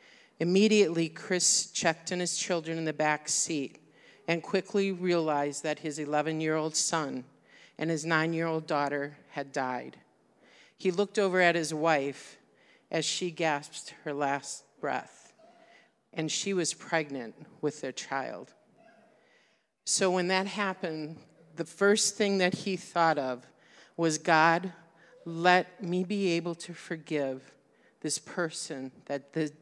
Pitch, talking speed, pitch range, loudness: 165 Hz, 140 wpm, 150-180 Hz, -30 LUFS